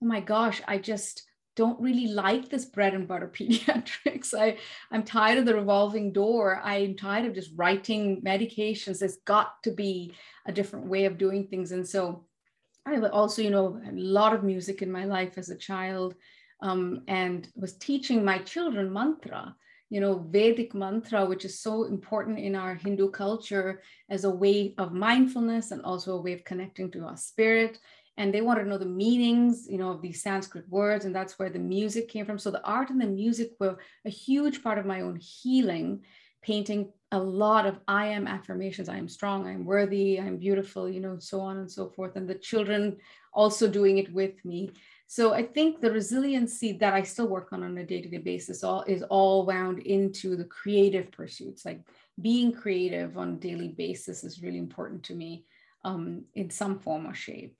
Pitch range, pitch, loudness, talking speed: 190-220 Hz, 200 Hz, -28 LUFS, 200 wpm